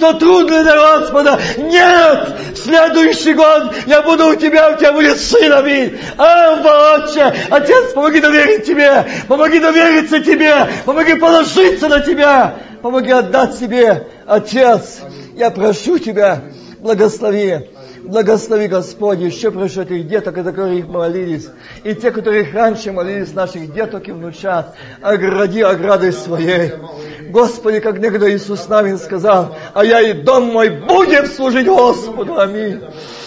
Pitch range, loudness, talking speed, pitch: 195-305 Hz, -11 LUFS, 135 wpm, 230 Hz